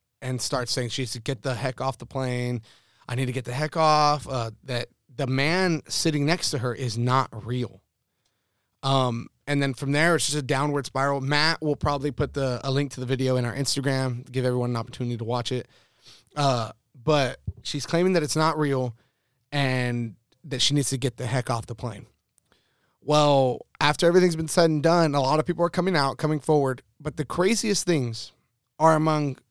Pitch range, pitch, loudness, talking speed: 125-150 Hz, 135 Hz, -25 LUFS, 205 wpm